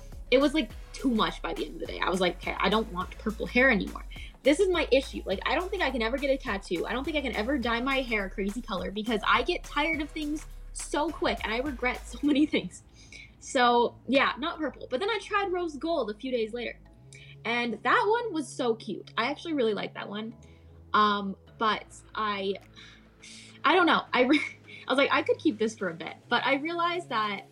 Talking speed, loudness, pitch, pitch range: 240 wpm, -28 LUFS, 245 Hz, 210-310 Hz